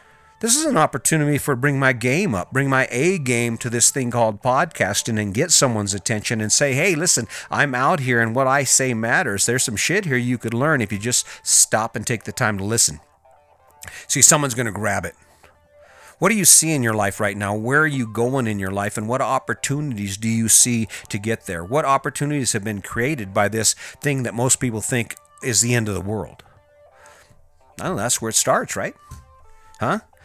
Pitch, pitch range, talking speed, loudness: 120 Hz, 110-135 Hz, 215 wpm, -19 LUFS